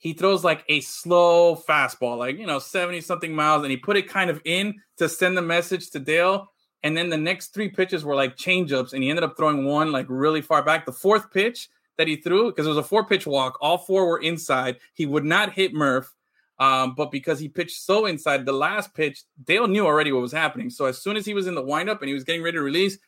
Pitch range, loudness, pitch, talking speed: 145-185 Hz, -22 LUFS, 165 Hz, 255 wpm